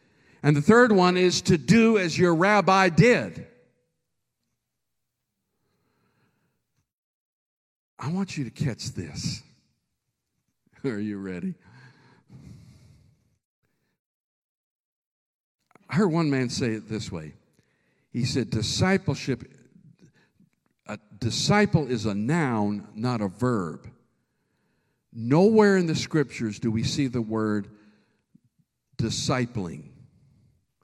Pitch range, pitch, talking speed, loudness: 110-180 Hz, 135 Hz, 95 wpm, -24 LUFS